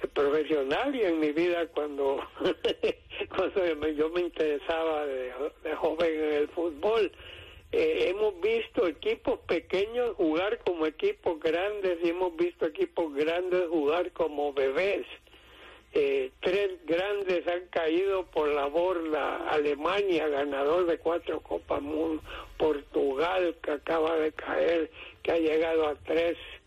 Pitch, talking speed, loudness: 170 Hz, 125 wpm, -29 LUFS